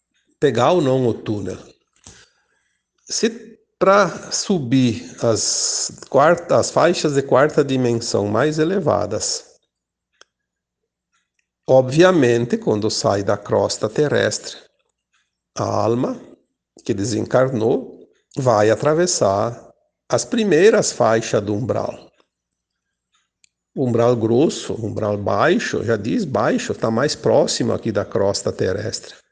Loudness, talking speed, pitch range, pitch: -18 LUFS, 100 wpm, 110-155 Hz, 120 Hz